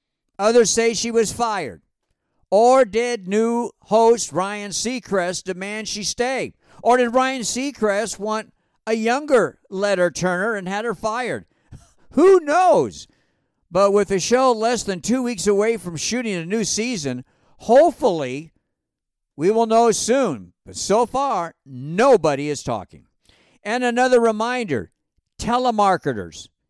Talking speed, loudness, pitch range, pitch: 130 wpm, -19 LUFS, 185-240 Hz, 220 Hz